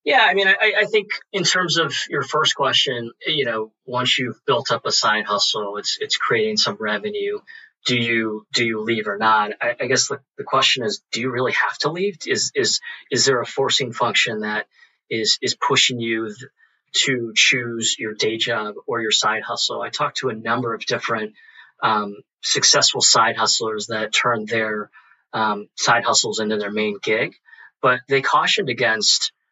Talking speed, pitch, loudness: 190 wpm, 120 Hz, -19 LUFS